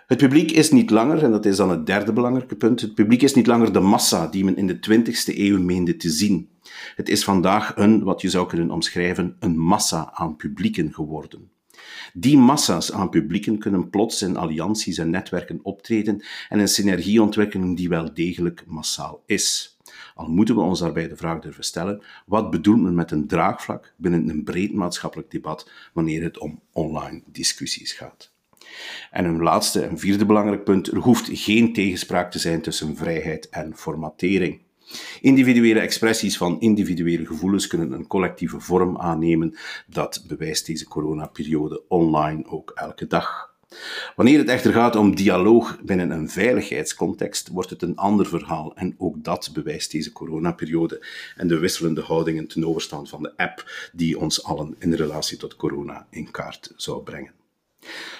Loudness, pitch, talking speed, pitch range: -21 LUFS, 95 Hz, 170 wpm, 85-110 Hz